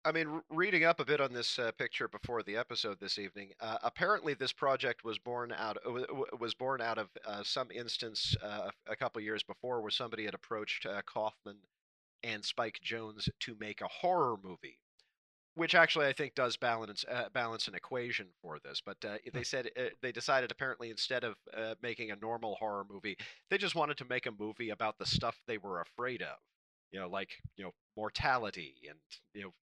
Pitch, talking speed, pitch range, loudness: 115 Hz, 205 wpm, 110-135 Hz, -36 LUFS